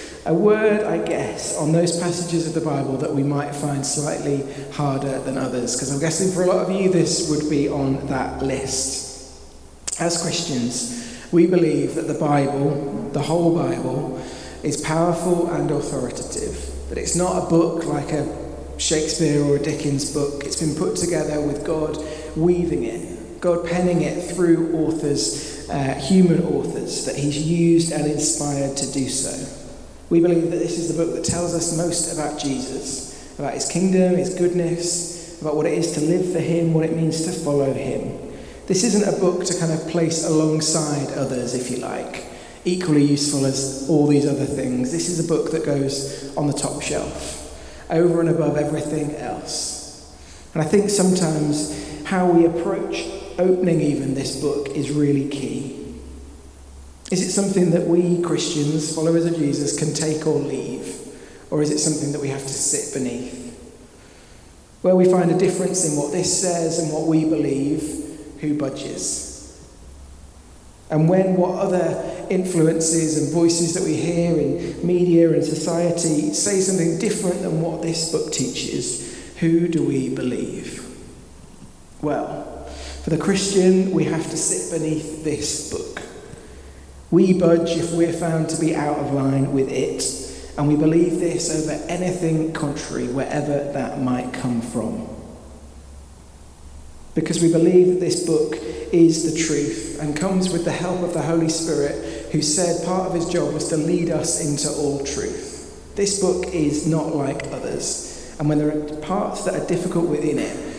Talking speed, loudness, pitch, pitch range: 165 wpm, -21 LUFS, 155 Hz, 140-170 Hz